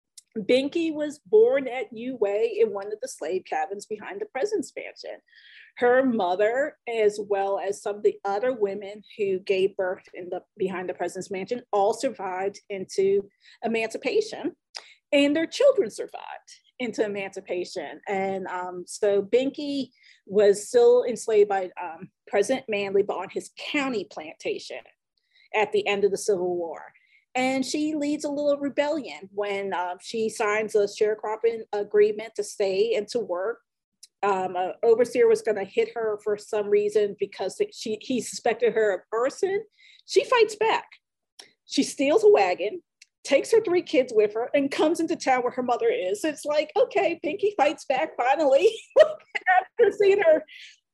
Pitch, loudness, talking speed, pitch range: 240 Hz, -25 LUFS, 160 wpm, 205-340 Hz